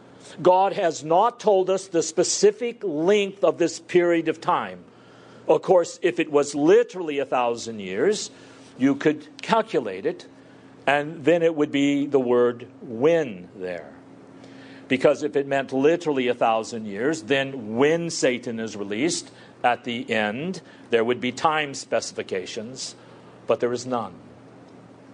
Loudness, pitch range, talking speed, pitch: -23 LUFS, 125-170 Hz, 145 wpm, 145 Hz